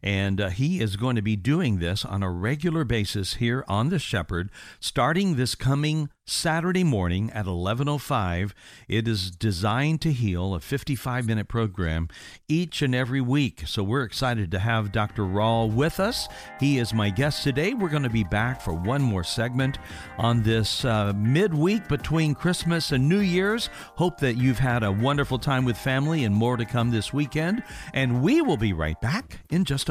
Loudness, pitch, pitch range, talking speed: -25 LUFS, 125 Hz, 105-145 Hz, 185 wpm